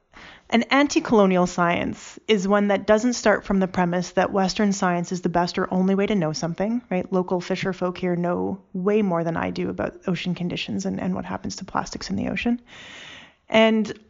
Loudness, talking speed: -23 LUFS, 200 wpm